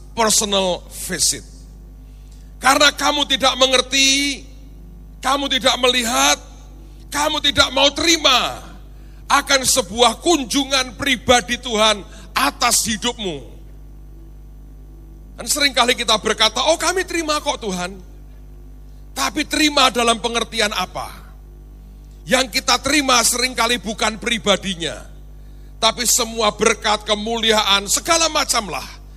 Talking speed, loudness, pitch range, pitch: 95 wpm, -16 LUFS, 220-280 Hz, 250 Hz